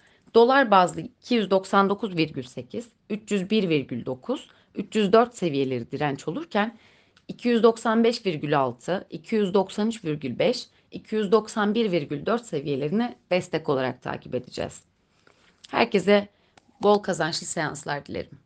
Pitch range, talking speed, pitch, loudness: 155-225 Hz, 70 wpm, 200 Hz, -24 LUFS